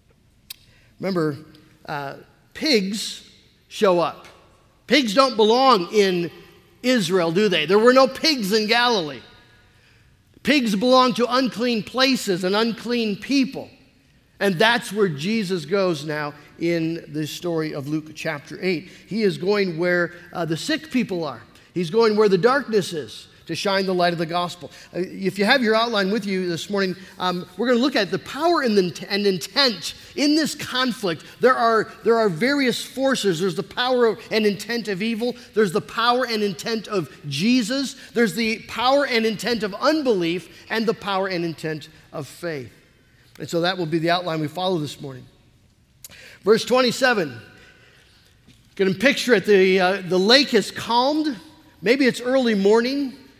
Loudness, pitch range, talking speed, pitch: -21 LUFS, 170-235 Hz, 165 wpm, 200 Hz